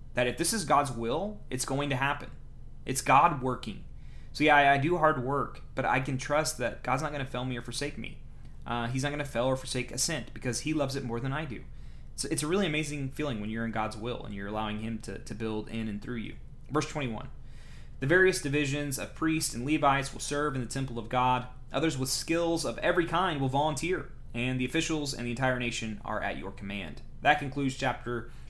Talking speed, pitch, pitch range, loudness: 235 wpm, 130 Hz, 120-150 Hz, -30 LUFS